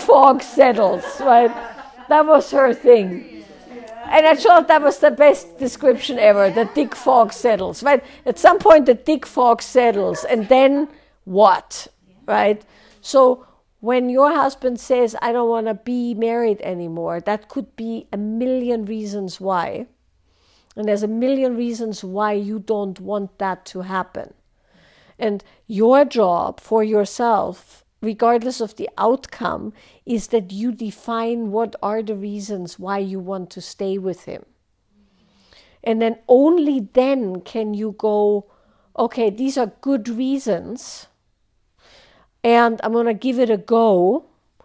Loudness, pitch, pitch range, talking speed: -18 LUFS, 230 Hz, 205-255 Hz, 145 wpm